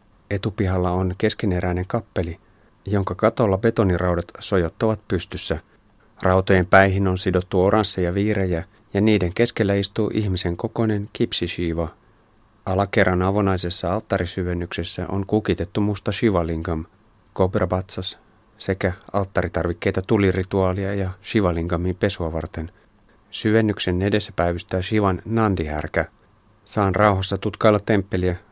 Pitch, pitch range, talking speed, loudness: 95 Hz, 90-105 Hz, 95 wpm, -22 LUFS